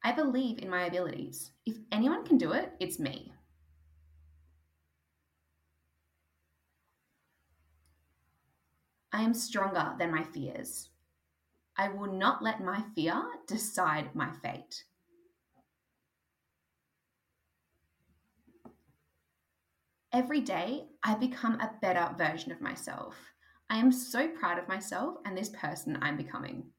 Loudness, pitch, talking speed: -33 LUFS, 150 Hz, 105 wpm